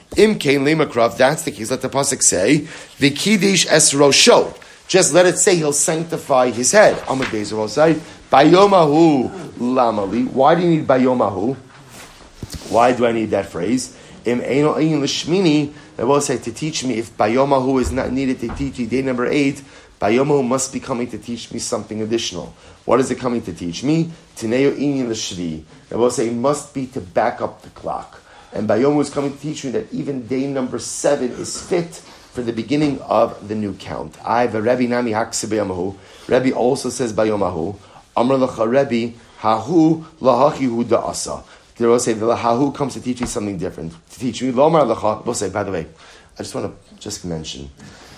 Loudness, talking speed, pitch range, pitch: -18 LUFS, 175 wpm, 115-145 Hz, 130 Hz